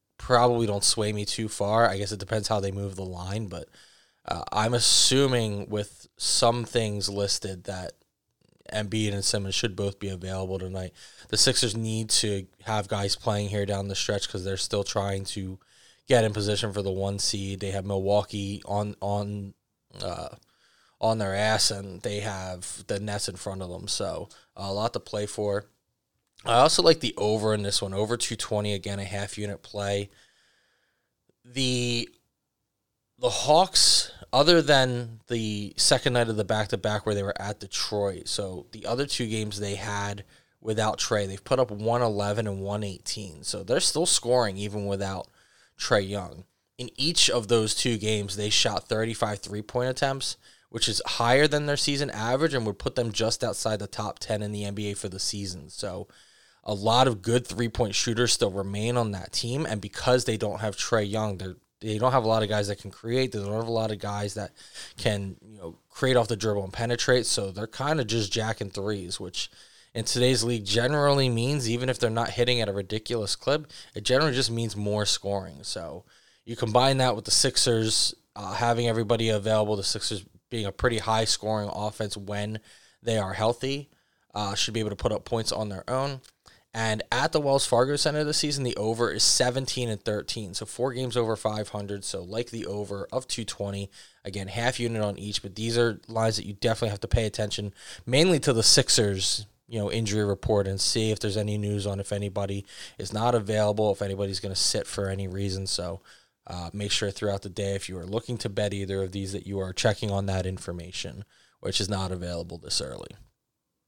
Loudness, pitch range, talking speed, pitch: -26 LUFS, 100-115 Hz, 200 wpm, 105 Hz